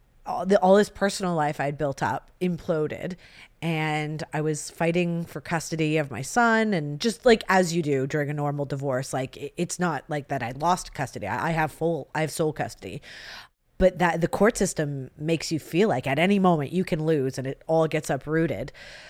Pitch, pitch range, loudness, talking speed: 160 Hz, 145-180 Hz, -25 LUFS, 195 wpm